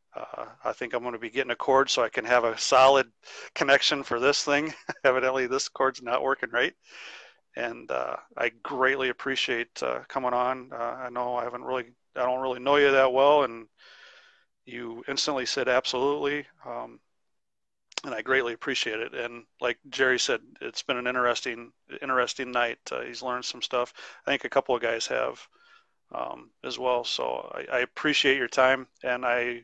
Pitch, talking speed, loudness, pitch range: 125 Hz, 185 wpm, -26 LUFS, 120-130 Hz